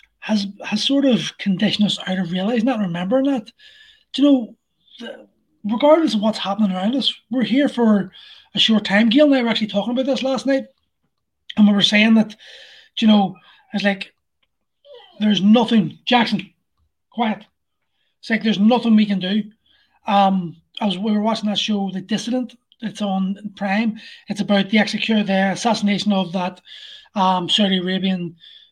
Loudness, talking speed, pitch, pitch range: -18 LUFS, 170 wpm, 215 Hz, 195-240 Hz